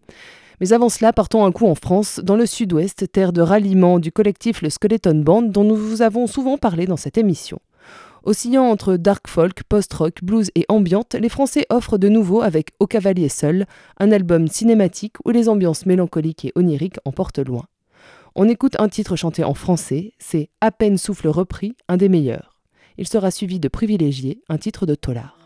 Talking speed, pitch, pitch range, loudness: 190 wpm, 195 Hz, 170-220 Hz, -18 LUFS